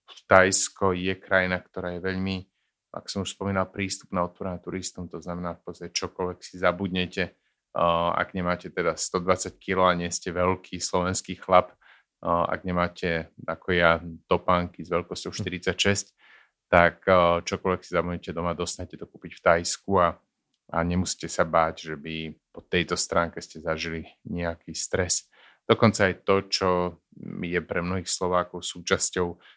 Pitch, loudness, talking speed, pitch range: 90 Hz, -26 LUFS, 150 wpm, 85-95 Hz